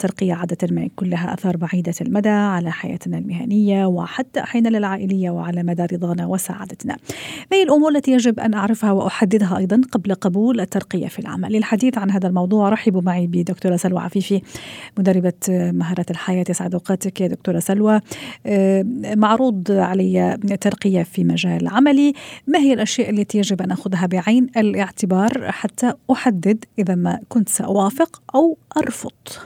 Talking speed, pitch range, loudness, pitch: 145 wpm, 185-225 Hz, -19 LUFS, 195 Hz